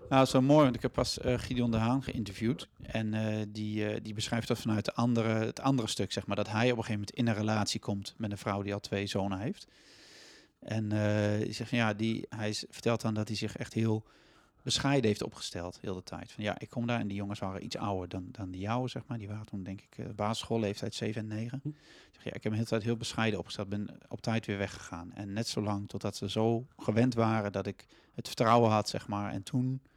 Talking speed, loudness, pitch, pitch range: 260 wpm, -33 LUFS, 110 Hz, 100-120 Hz